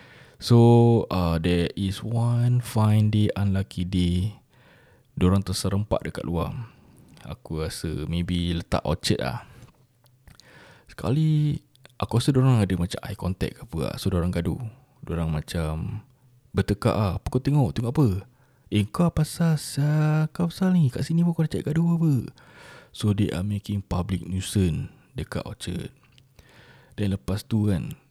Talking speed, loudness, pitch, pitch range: 145 wpm, -25 LUFS, 110 Hz, 90-130 Hz